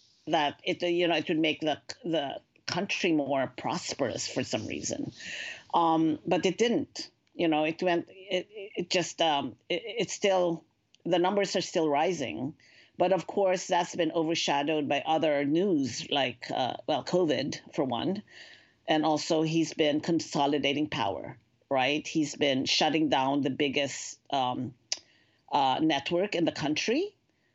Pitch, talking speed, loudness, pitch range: 160 Hz, 150 wpm, -29 LUFS, 150-180 Hz